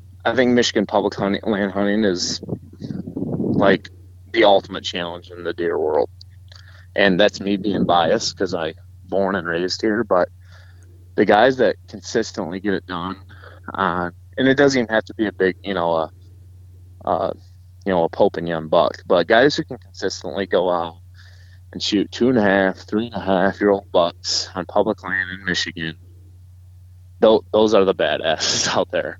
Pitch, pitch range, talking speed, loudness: 95 Hz, 90-100 Hz, 180 wpm, -20 LUFS